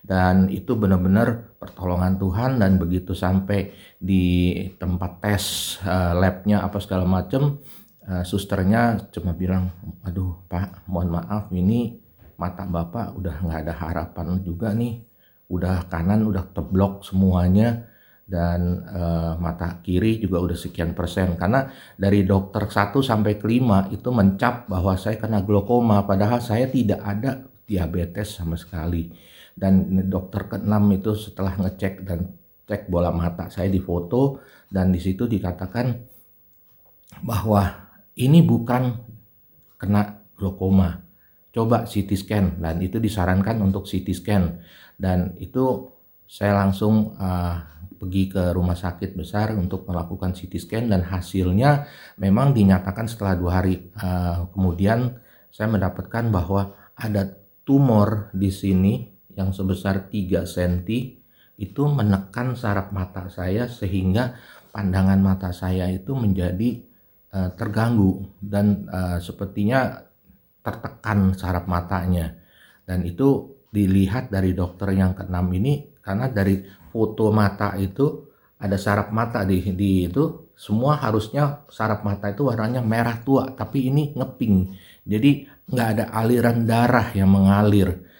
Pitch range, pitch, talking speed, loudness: 90-110 Hz, 100 Hz, 125 wpm, -22 LUFS